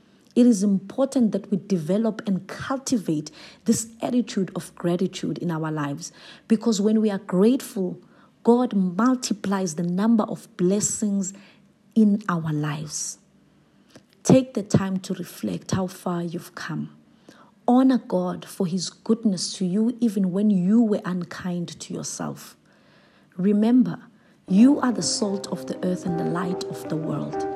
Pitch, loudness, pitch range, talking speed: 195 Hz, -24 LUFS, 180-225 Hz, 145 wpm